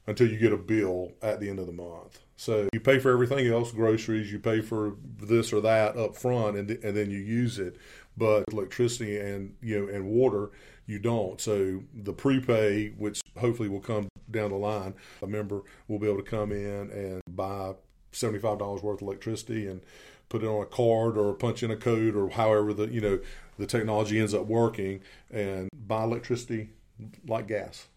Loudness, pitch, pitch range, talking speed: -29 LUFS, 105 Hz, 100-115 Hz, 200 wpm